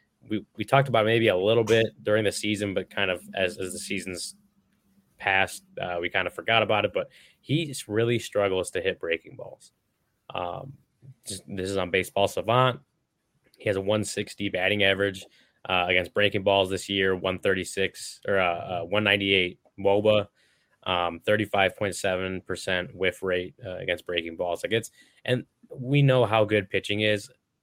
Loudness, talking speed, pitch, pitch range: -26 LUFS, 160 wpm, 105 Hz, 95-115 Hz